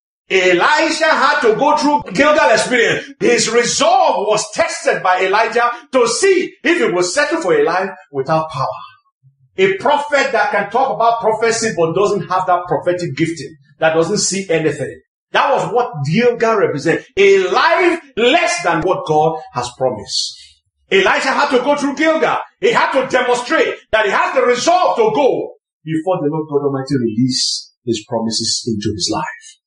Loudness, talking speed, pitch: -15 LUFS, 165 wpm, 220 Hz